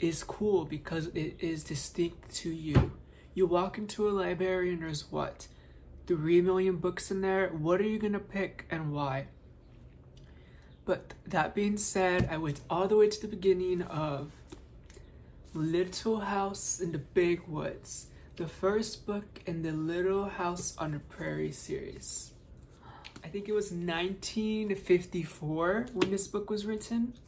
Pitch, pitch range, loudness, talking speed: 180 Hz, 155-195 Hz, -32 LUFS, 150 wpm